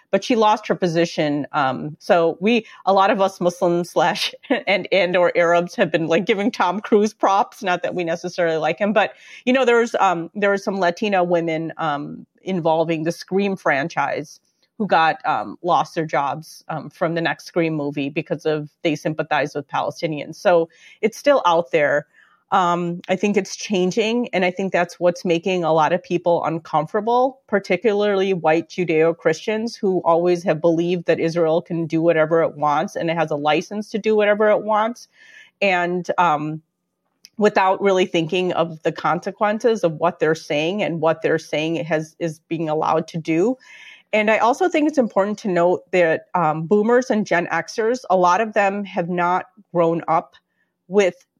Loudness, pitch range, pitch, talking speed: -20 LUFS, 165-205 Hz, 175 Hz, 190 wpm